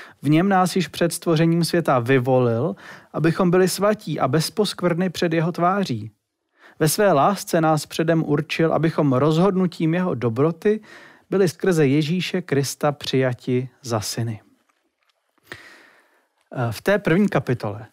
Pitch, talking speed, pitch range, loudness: 160 Hz, 125 wpm, 135-180 Hz, -21 LUFS